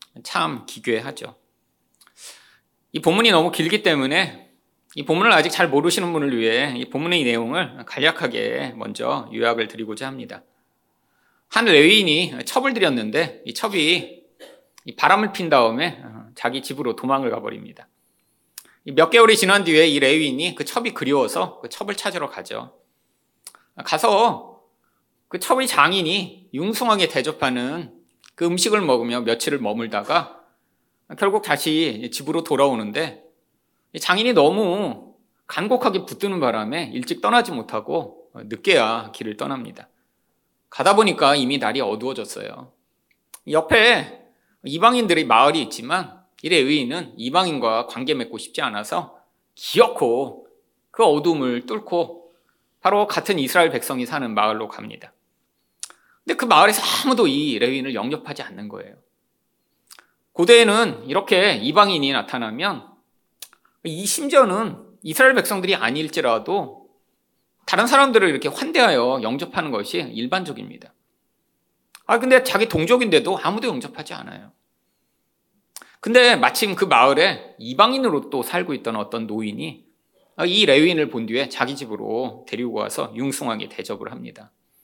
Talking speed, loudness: 295 characters per minute, -19 LUFS